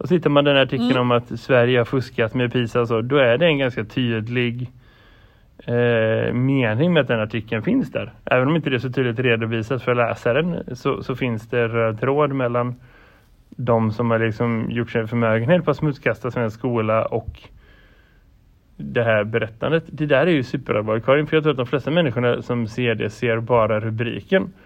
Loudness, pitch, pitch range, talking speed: -20 LUFS, 120 Hz, 115-135 Hz, 190 wpm